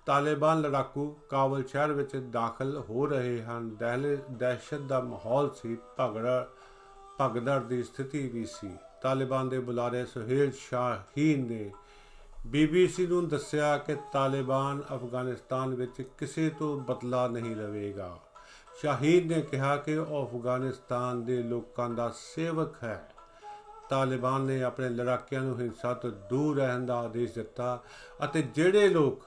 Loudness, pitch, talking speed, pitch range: -31 LUFS, 130 Hz, 130 wpm, 125-145 Hz